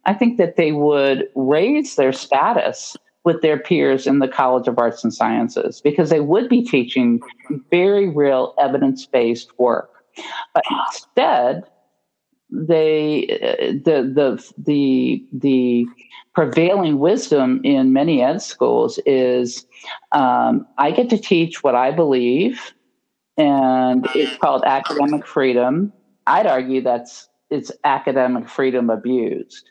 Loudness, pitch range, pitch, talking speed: -17 LUFS, 125-190 Hz, 140 Hz, 125 wpm